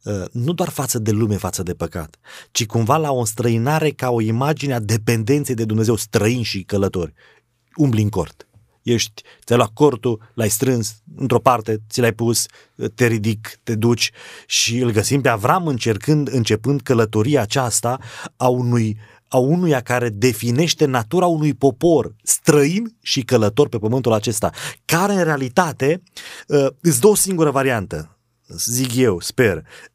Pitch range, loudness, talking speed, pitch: 110-145 Hz, -18 LUFS, 150 wpm, 120 Hz